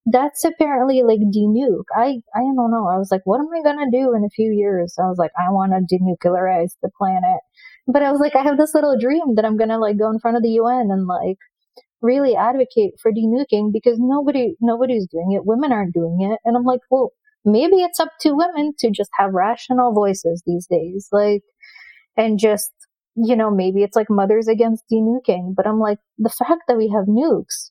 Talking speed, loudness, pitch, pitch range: 220 wpm, -18 LUFS, 225 Hz, 205-260 Hz